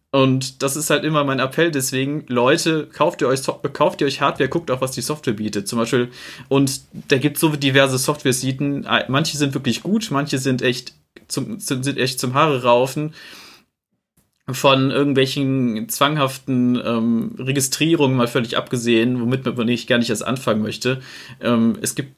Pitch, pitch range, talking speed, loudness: 130 Hz, 125-140 Hz, 165 wpm, -19 LUFS